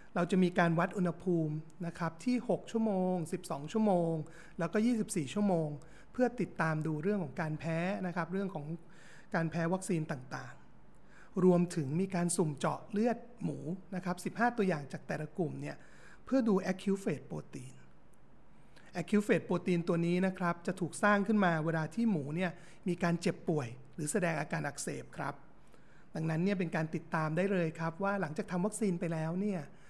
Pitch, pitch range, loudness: 175 Hz, 160-195 Hz, -34 LUFS